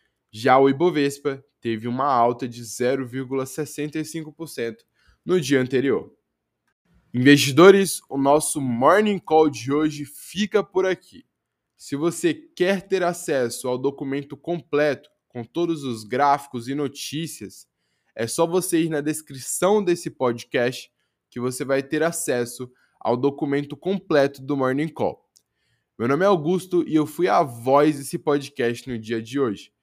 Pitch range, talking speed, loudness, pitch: 130-165 Hz, 140 wpm, -22 LUFS, 145 Hz